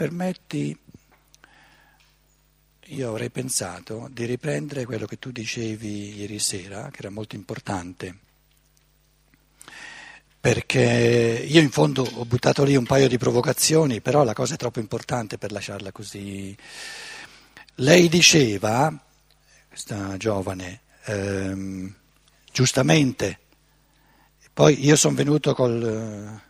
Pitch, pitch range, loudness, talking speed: 120 Hz, 105-140 Hz, -22 LUFS, 110 wpm